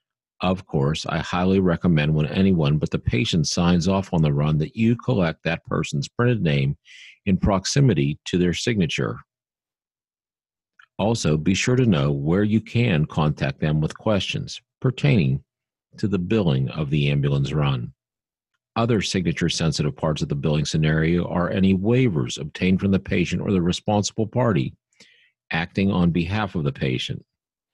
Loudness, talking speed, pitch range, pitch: -22 LUFS, 155 wpm, 75-105 Hz, 90 Hz